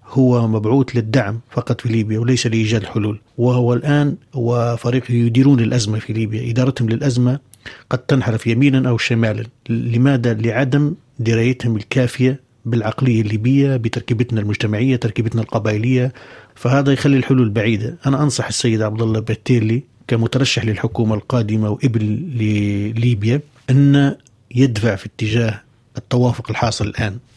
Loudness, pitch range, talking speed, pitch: -17 LUFS, 115-130 Hz, 120 wpm, 120 Hz